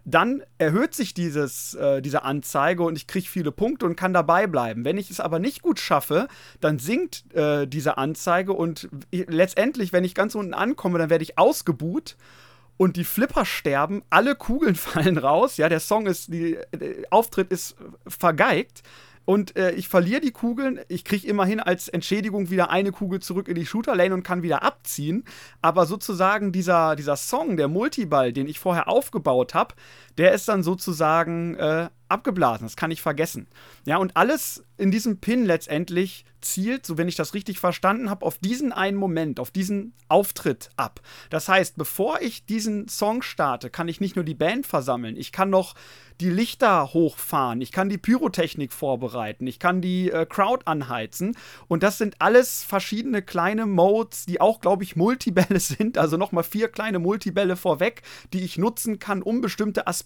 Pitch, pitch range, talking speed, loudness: 185 Hz, 165-205 Hz, 180 wpm, -23 LUFS